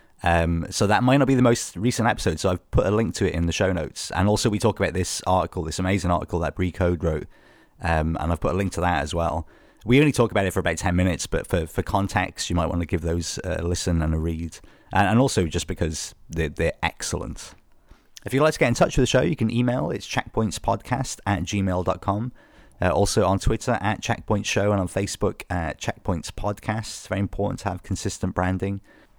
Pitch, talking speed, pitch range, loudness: 95 Hz, 230 wpm, 85-110 Hz, -24 LUFS